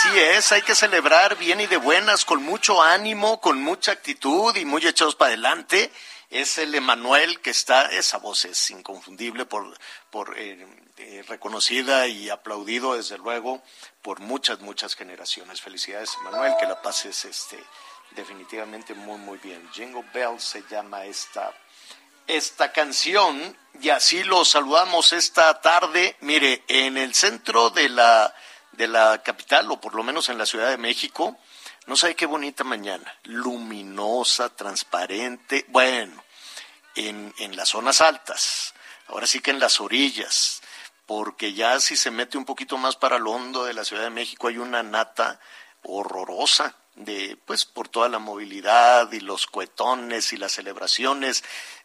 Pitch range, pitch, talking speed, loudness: 110-145 Hz, 125 Hz, 155 wpm, -21 LUFS